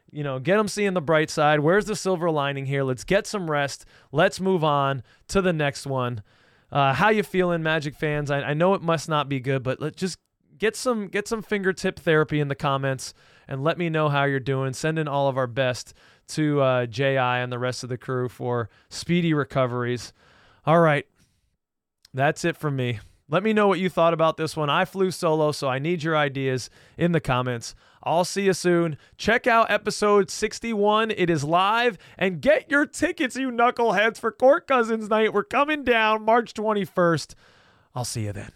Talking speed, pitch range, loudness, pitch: 205 wpm, 135-200 Hz, -23 LUFS, 155 Hz